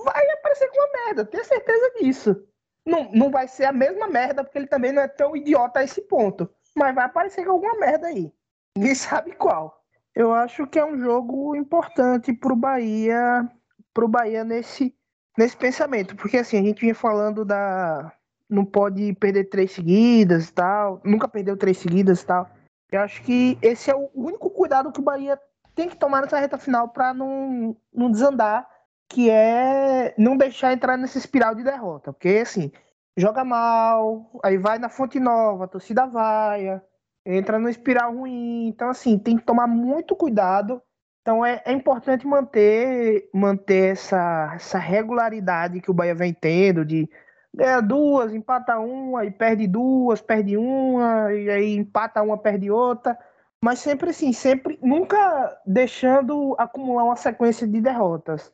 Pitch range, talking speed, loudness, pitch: 205-270 Hz, 170 wpm, -21 LUFS, 235 Hz